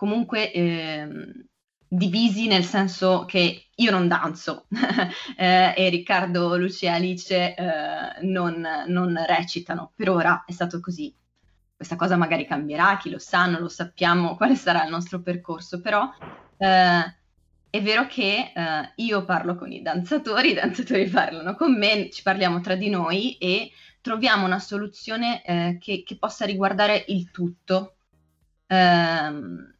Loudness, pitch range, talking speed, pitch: -23 LUFS, 170-200 Hz, 145 wpm, 180 Hz